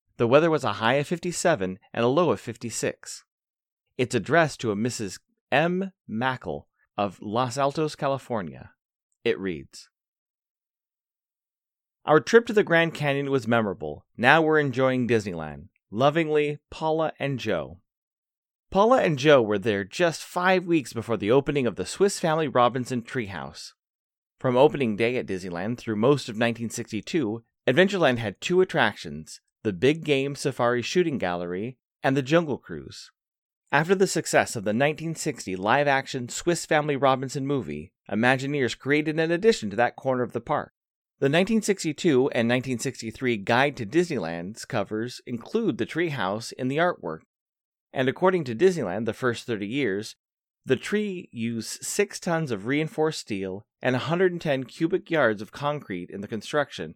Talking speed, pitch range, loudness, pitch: 150 wpm, 115-160 Hz, -25 LUFS, 135 Hz